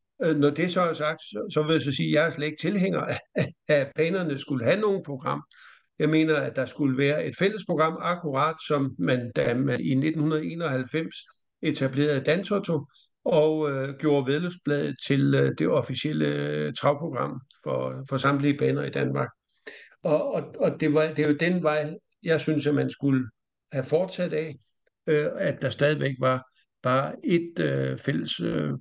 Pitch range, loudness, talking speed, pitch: 135-160 Hz, -26 LUFS, 175 wpm, 150 Hz